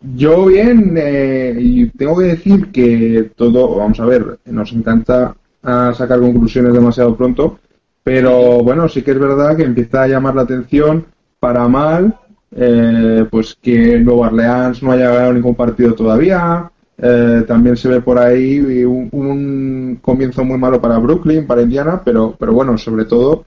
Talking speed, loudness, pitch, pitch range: 160 wpm, -12 LUFS, 125 Hz, 120-140 Hz